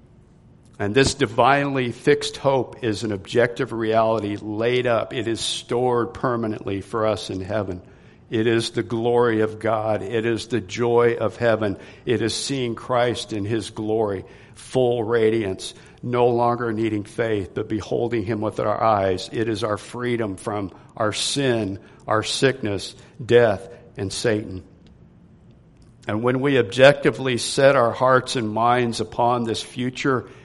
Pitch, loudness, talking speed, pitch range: 115 Hz, -22 LUFS, 145 wpm, 110-120 Hz